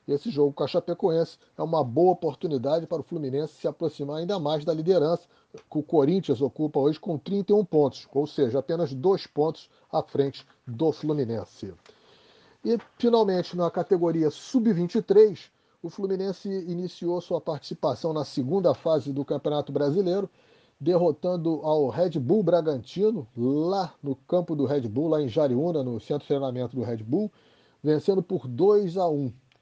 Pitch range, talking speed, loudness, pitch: 145-180 Hz, 155 wpm, -26 LUFS, 160 Hz